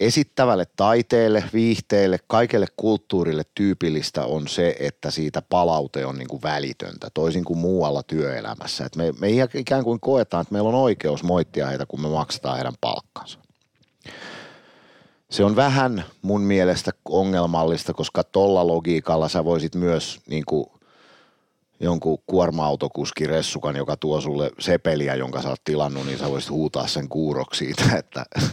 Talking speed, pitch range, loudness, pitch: 145 wpm, 75-100 Hz, -22 LUFS, 80 Hz